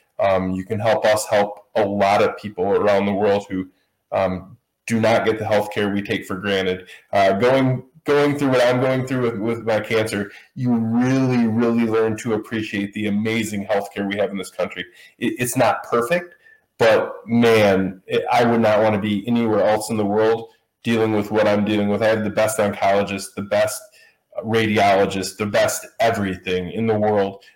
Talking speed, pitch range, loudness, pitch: 195 wpm, 100-115 Hz, -20 LUFS, 110 Hz